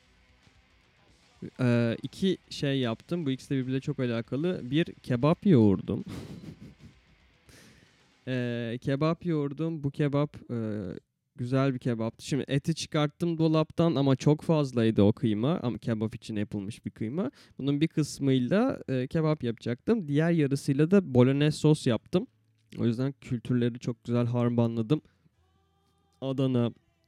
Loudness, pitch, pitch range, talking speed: -28 LUFS, 130 Hz, 115-150 Hz, 120 wpm